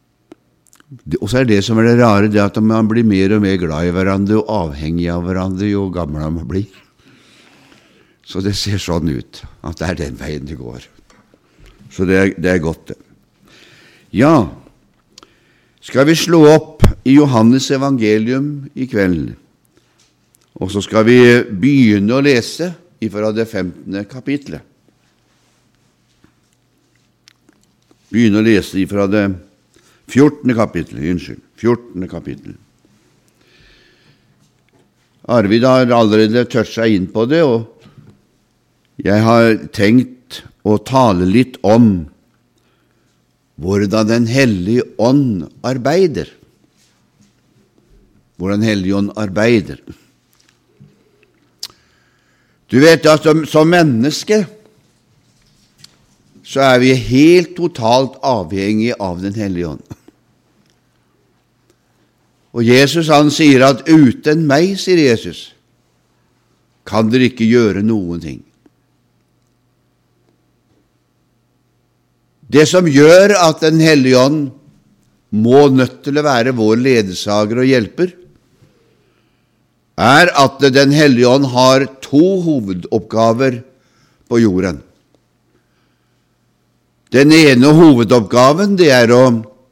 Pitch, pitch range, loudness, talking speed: 115 Hz, 95-135 Hz, -12 LUFS, 110 wpm